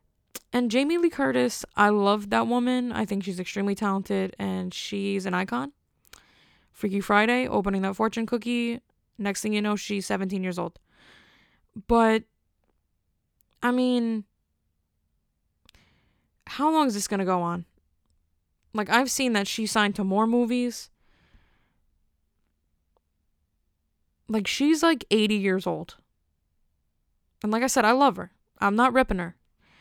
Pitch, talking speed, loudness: 200 Hz, 135 wpm, -25 LUFS